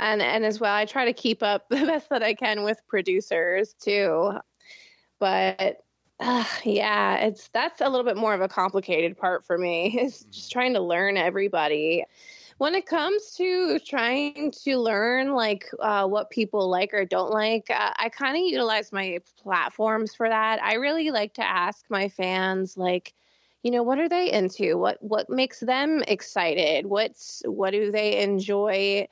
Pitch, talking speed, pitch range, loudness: 215 Hz, 175 wpm, 195-250 Hz, -25 LUFS